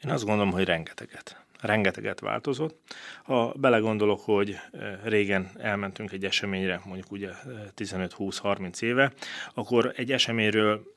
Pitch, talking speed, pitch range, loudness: 105 Hz, 115 wpm, 95-120 Hz, -27 LUFS